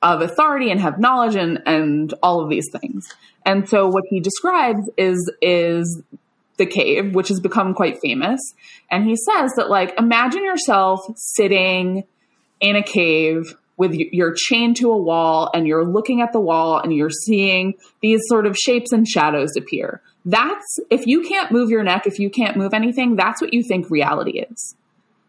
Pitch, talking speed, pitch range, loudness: 200 Hz, 185 wpm, 180-235 Hz, -17 LUFS